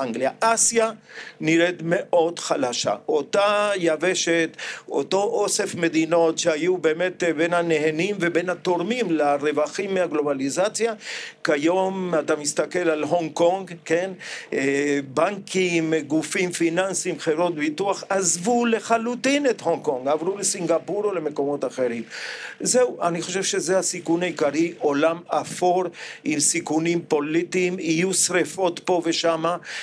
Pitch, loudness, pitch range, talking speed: 170 Hz, -22 LUFS, 160-190 Hz, 110 wpm